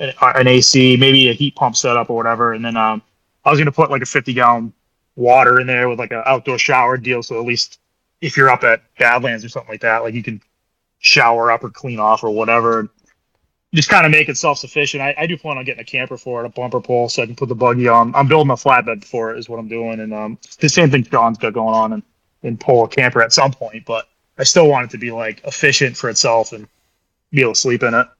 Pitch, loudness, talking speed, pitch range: 120 Hz, -14 LUFS, 260 wpm, 115-135 Hz